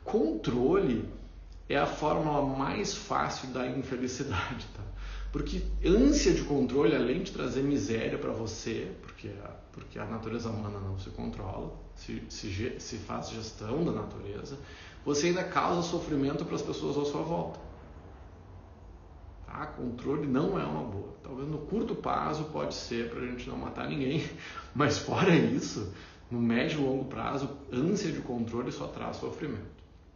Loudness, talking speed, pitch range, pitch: -32 LUFS, 145 wpm, 95-140 Hz, 125 Hz